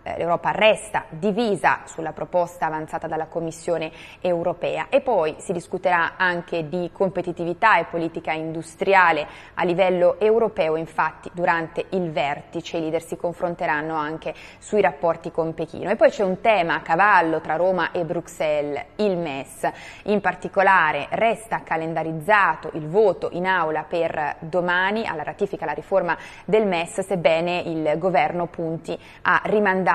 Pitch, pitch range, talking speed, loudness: 175 Hz, 160-190 Hz, 140 wpm, -22 LUFS